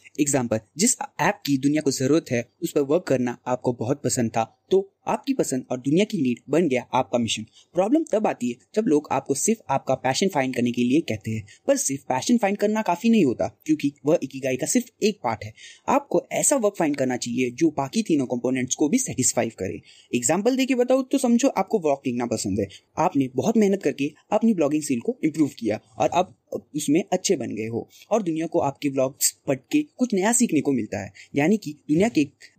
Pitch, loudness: 150 Hz, -23 LUFS